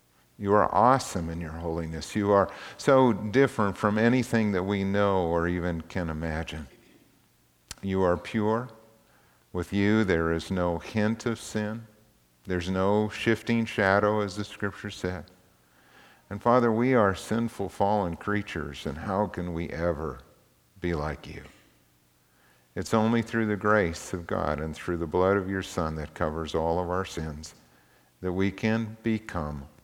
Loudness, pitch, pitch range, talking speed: -27 LUFS, 95 Hz, 80-105 Hz, 155 wpm